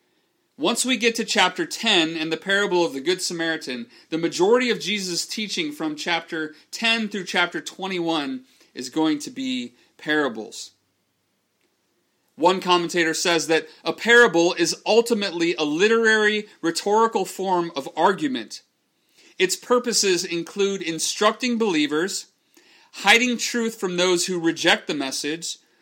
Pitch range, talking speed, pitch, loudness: 165-230 Hz, 130 wpm, 185 Hz, -21 LUFS